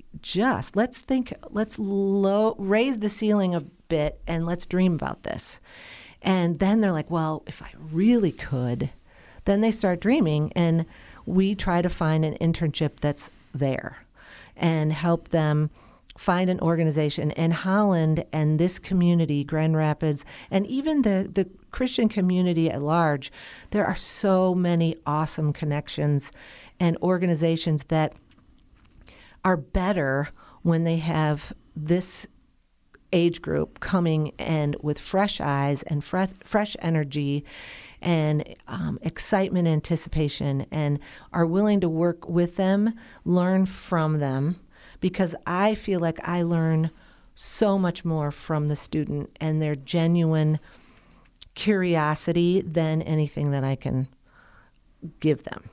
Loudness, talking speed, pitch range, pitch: -25 LUFS, 130 wpm, 150-185 Hz, 165 Hz